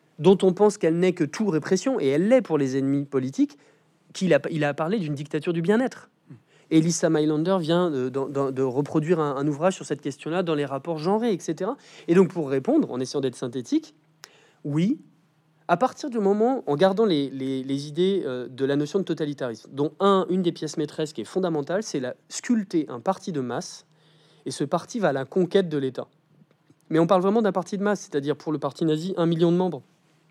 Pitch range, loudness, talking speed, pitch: 145-185 Hz, -24 LUFS, 215 wpm, 160 Hz